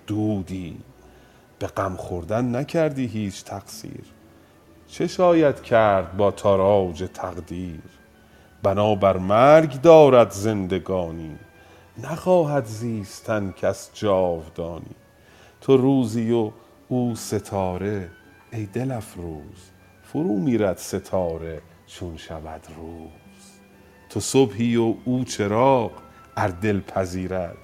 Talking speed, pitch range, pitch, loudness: 95 wpm, 90-115 Hz, 100 Hz, -21 LUFS